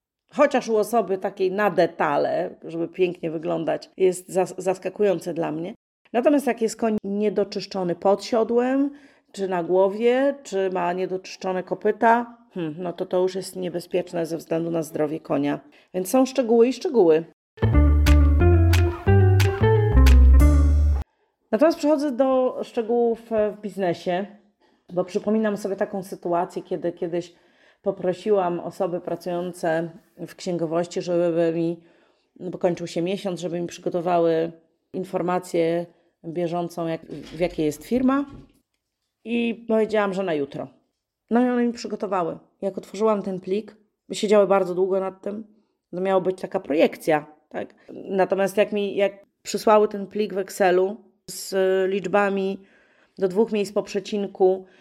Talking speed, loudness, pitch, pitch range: 130 wpm, -23 LUFS, 190 Hz, 170-210 Hz